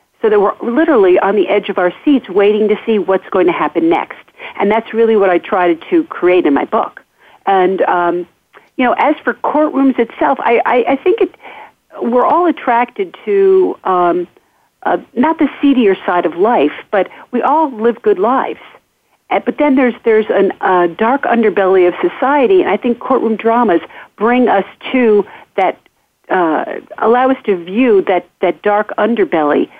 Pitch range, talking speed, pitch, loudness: 195-290 Hz, 180 wpm, 235 Hz, -13 LUFS